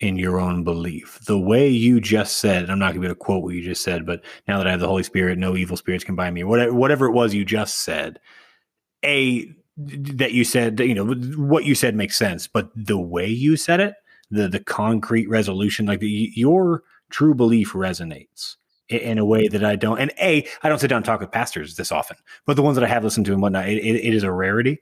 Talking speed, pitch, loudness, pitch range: 245 wpm, 110 Hz, -20 LUFS, 95-125 Hz